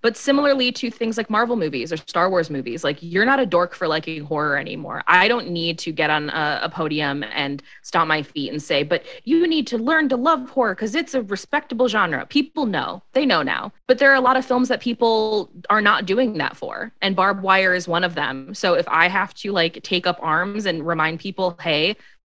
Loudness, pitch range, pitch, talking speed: -20 LUFS, 165-250 Hz, 195 Hz, 235 wpm